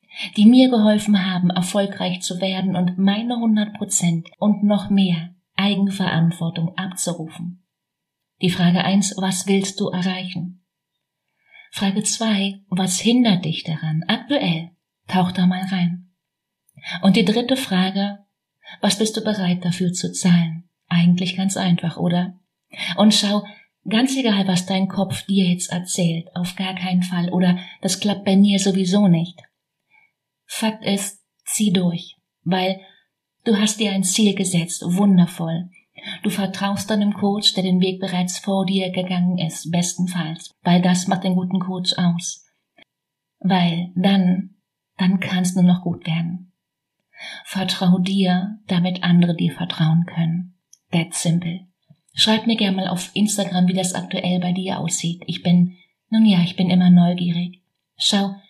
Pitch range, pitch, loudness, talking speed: 175-200 Hz, 185 Hz, -19 LUFS, 145 wpm